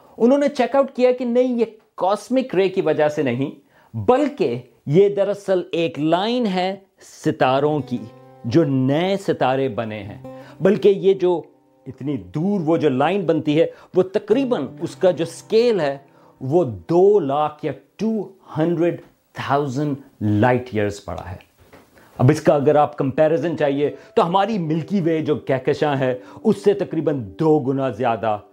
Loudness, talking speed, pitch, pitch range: -20 LUFS, 155 wpm, 155 Hz, 135-195 Hz